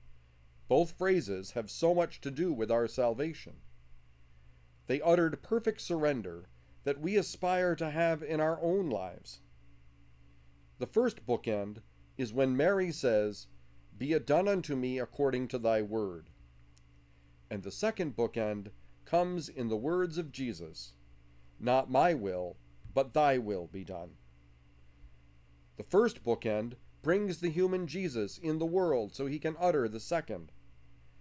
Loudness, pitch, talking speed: -33 LUFS, 115 Hz, 140 wpm